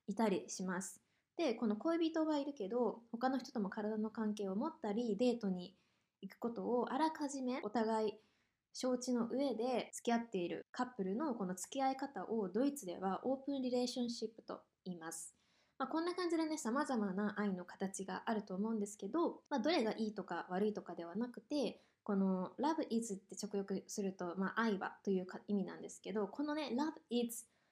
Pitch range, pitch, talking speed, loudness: 195-260 Hz, 225 Hz, 390 characters per minute, -40 LUFS